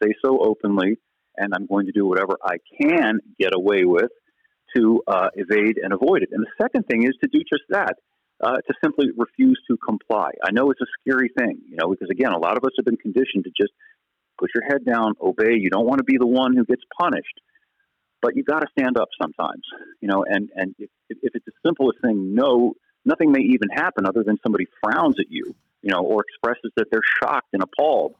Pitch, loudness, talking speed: 140 Hz, -21 LUFS, 225 wpm